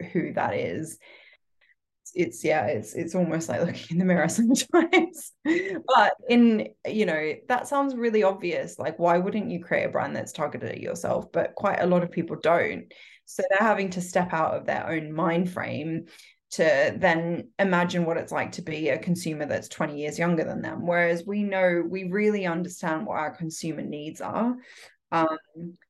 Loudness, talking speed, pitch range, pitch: -26 LUFS, 185 wpm, 165-210 Hz, 175 Hz